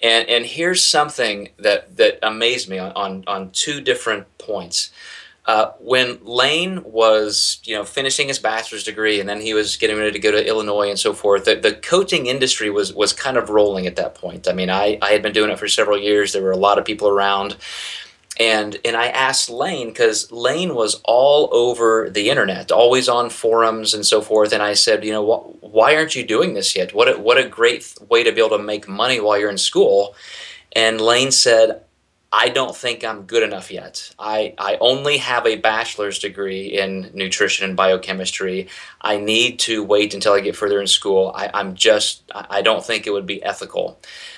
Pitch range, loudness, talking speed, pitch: 105-145 Hz, -17 LUFS, 205 wpm, 110 Hz